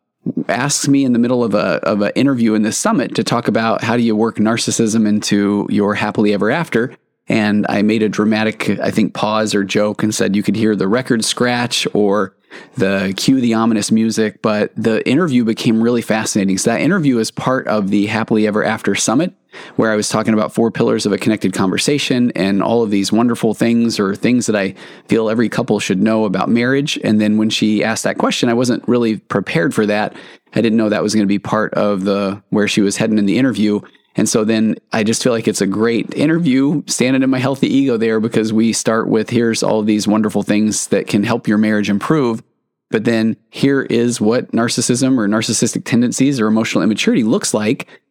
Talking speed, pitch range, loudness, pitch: 215 wpm, 105-120 Hz, -15 LUFS, 110 Hz